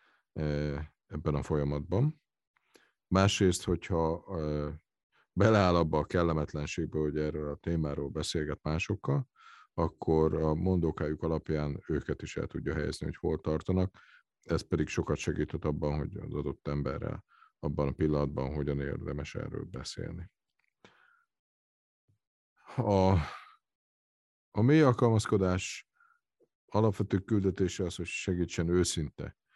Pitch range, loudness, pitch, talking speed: 75-95 Hz, -32 LUFS, 80 Hz, 110 wpm